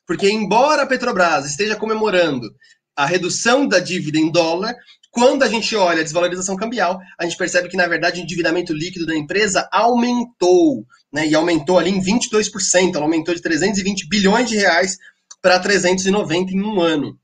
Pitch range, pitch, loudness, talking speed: 175-215 Hz, 185 Hz, -17 LUFS, 170 wpm